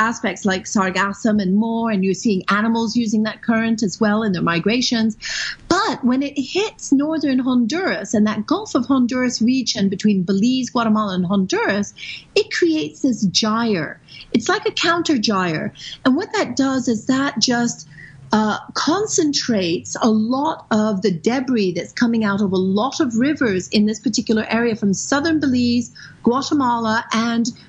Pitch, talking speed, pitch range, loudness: 230 Hz, 160 wpm, 210-265 Hz, -19 LUFS